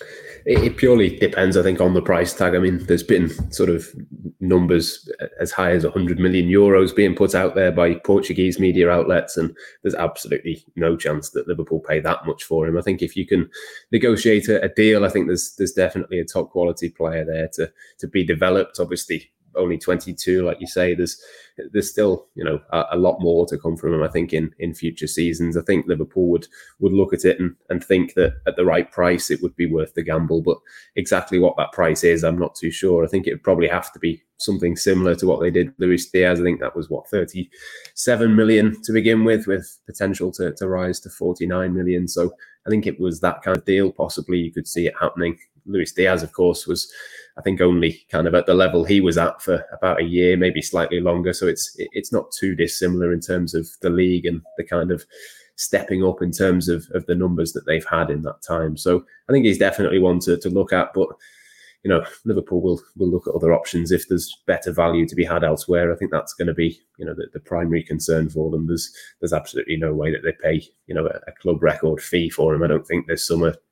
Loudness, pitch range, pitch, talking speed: -20 LUFS, 85-95 Hz, 90 Hz, 235 wpm